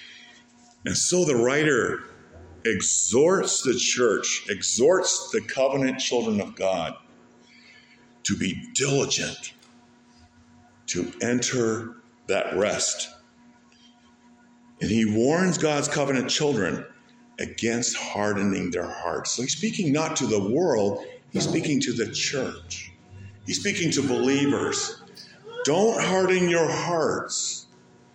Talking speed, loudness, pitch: 105 wpm, -24 LUFS, 135 Hz